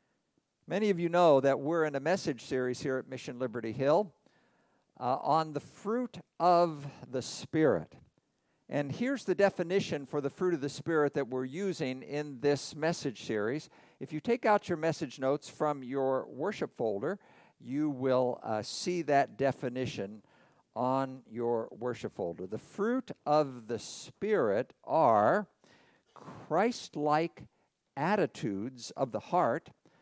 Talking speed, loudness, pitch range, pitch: 145 wpm, -32 LUFS, 130-170 Hz, 145 Hz